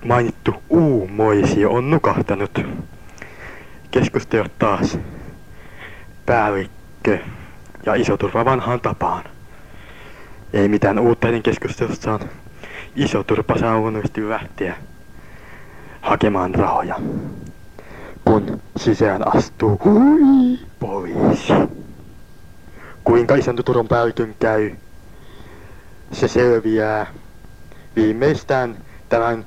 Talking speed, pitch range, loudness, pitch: 75 wpm, 105-125 Hz, -18 LUFS, 115 Hz